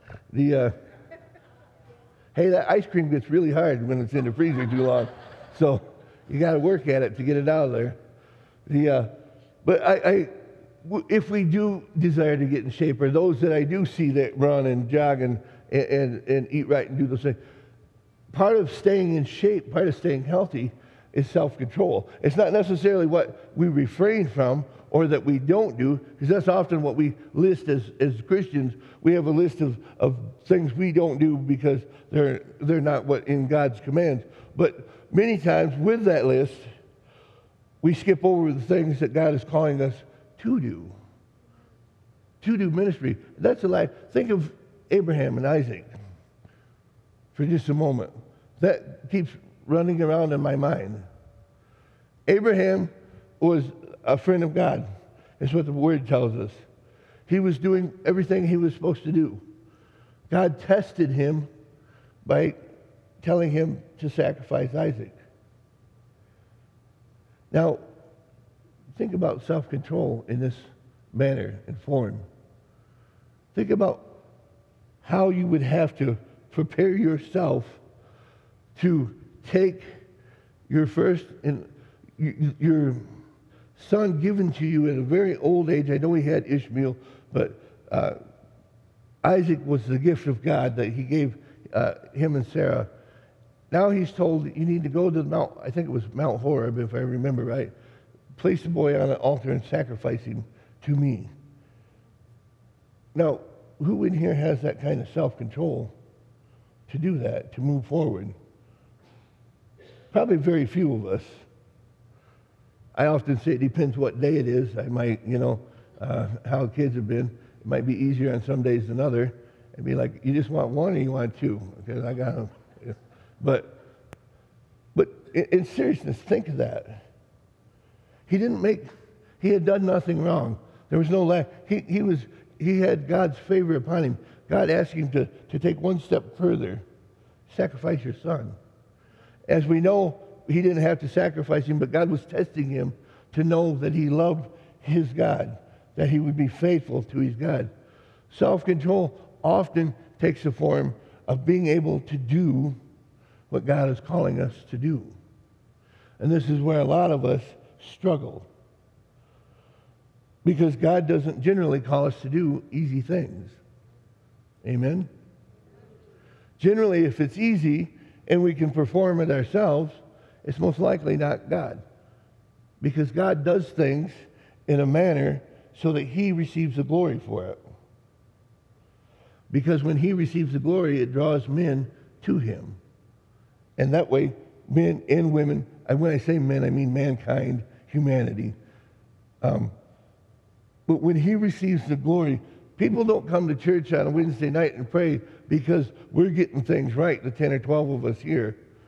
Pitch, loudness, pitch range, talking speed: 140 Hz, -24 LUFS, 120-165 Hz, 155 wpm